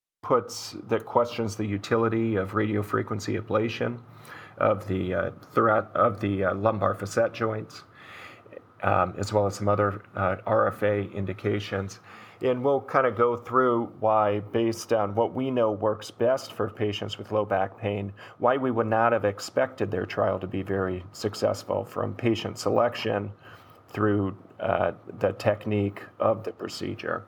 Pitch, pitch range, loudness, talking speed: 105 Hz, 100-115 Hz, -27 LUFS, 150 wpm